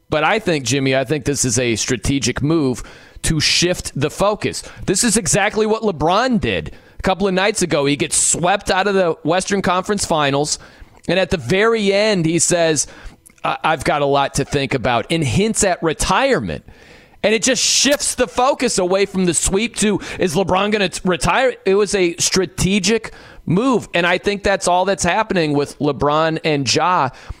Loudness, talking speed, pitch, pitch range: -17 LUFS, 190 wpm, 180 Hz, 150-200 Hz